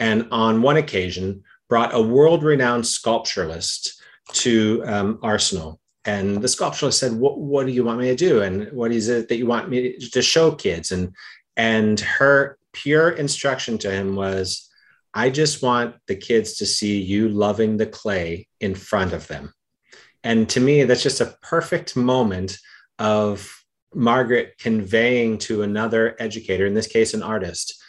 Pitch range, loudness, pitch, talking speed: 105-130 Hz, -20 LUFS, 115 Hz, 170 wpm